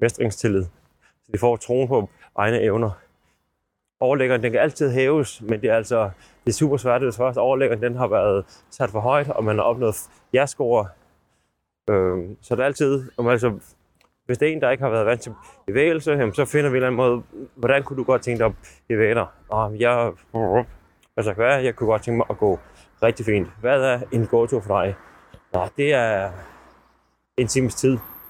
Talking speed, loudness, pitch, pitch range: 195 wpm, -21 LUFS, 120 Hz, 105-130 Hz